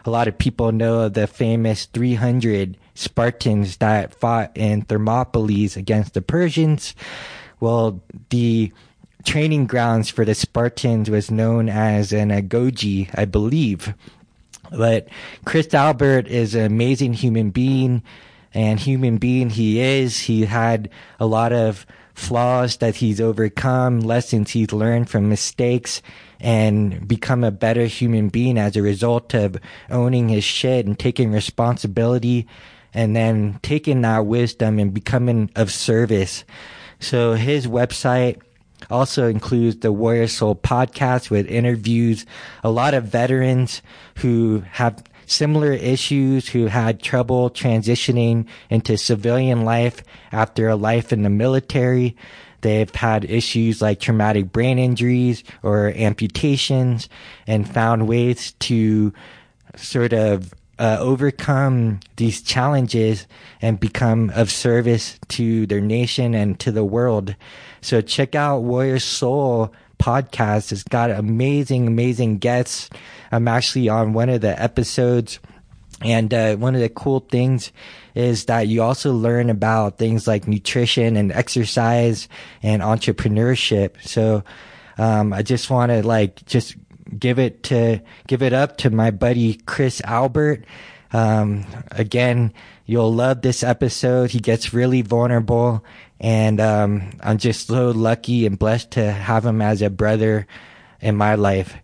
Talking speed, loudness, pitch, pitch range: 135 wpm, -19 LUFS, 115 Hz, 110-125 Hz